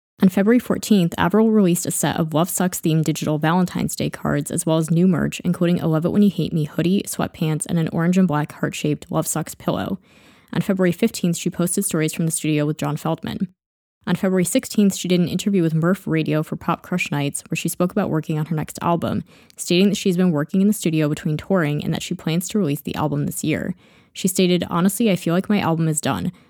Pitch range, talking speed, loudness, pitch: 160-190 Hz, 240 wpm, -20 LUFS, 175 Hz